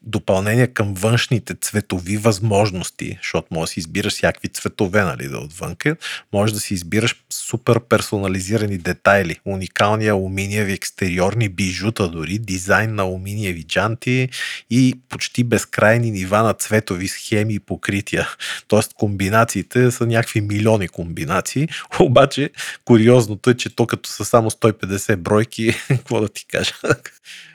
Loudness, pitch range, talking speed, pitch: -19 LUFS, 100-115 Hz, 130 wpm, 110 Hz